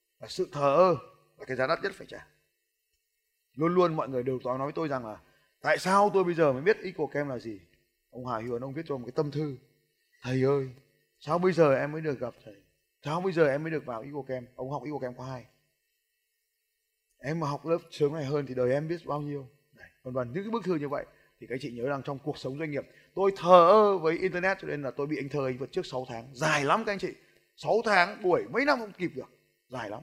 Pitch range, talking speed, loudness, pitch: 130-185 Hz, 260 wpm, -29 LUFS, 145 Hz